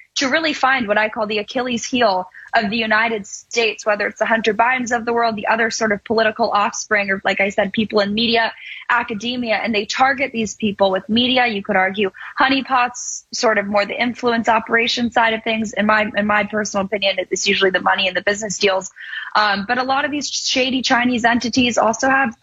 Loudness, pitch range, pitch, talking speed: -18 LUFS, 205-240 Hz, 225 Hz, 215 wpm